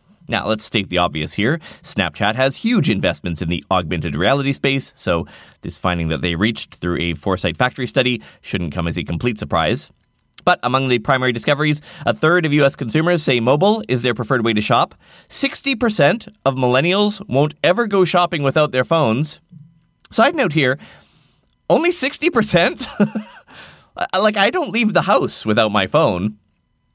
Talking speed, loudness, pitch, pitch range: 165 wpm, -18 LUFS, 130 Hz, 105-175 Hz